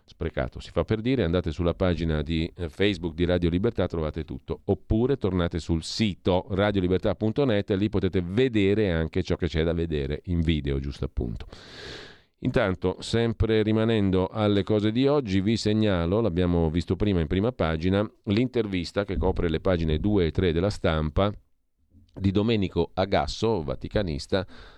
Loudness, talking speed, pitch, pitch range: -26 LUFS, 155 wpm, 95 Hz, 85-105 Hz